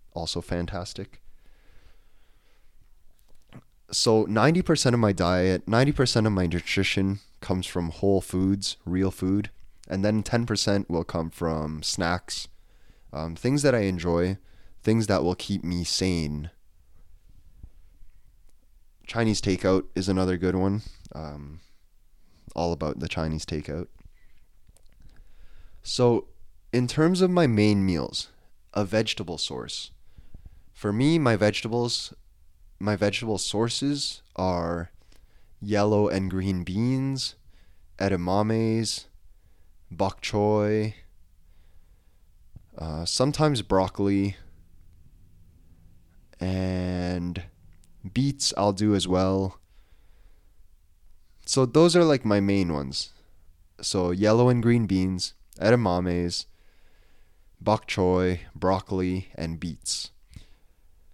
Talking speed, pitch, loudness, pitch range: 95 wpm, 90 Hz, -25 LUFS, 85-105 Hz